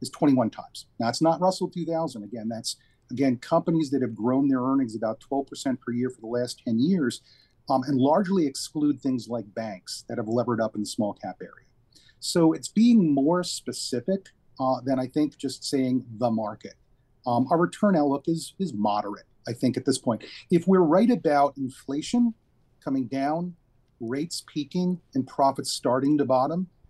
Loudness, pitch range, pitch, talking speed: -26 LUFS, 120-155 Hz, 130 Hz, 180 wpm